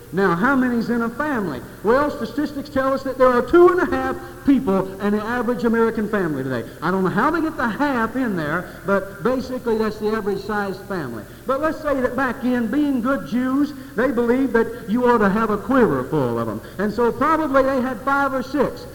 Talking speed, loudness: 220 wpm, -20 LUFS